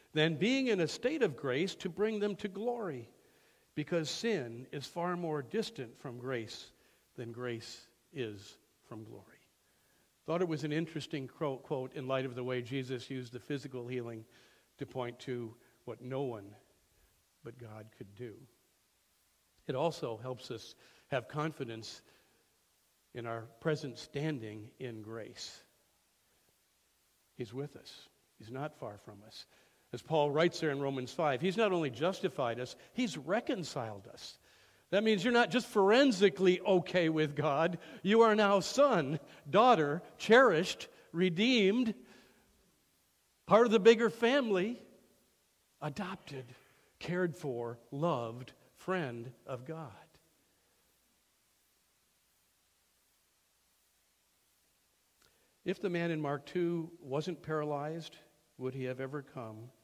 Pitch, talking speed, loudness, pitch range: 145 Hz, 125 wpm, -33 LUFS, 125-180 Hz